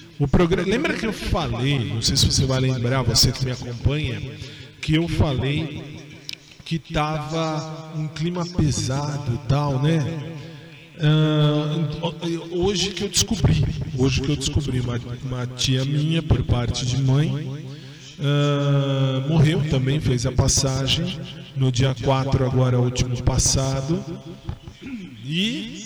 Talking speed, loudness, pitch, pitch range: 135 wpm, -22 LUFS, 140 Hz, 130-155 Hz